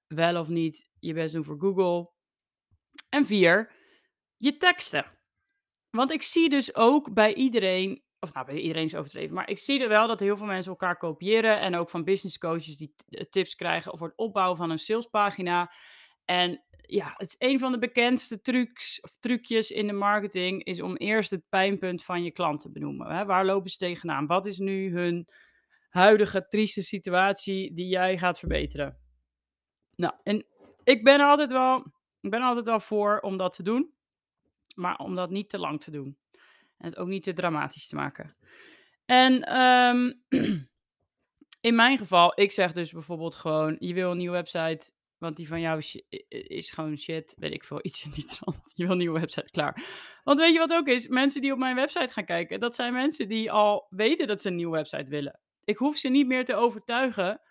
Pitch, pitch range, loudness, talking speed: 195 Hz, 170-245 Hz, -26 LUFS, 195 wpm